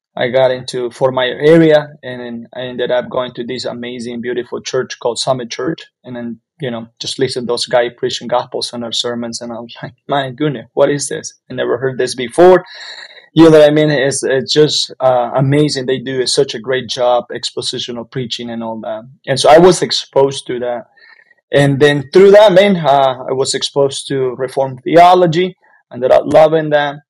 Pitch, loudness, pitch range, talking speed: 130 Hz, -13 LUFS, 120-145 Hz, 205 wpm